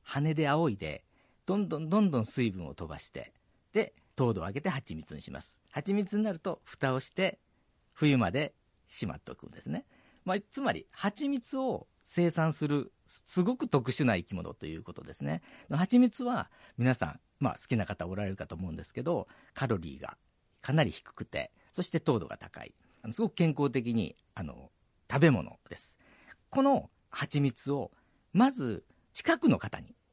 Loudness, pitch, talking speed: -32 LUFS, 140 Hz, 315 characters per minute